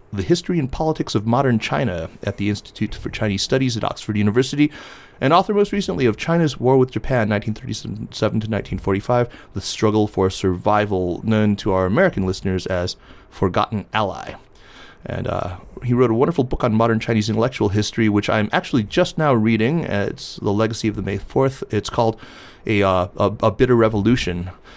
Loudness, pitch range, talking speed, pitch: -20 LUFS, 100-125 Hz, 175 wpm, 110 Hz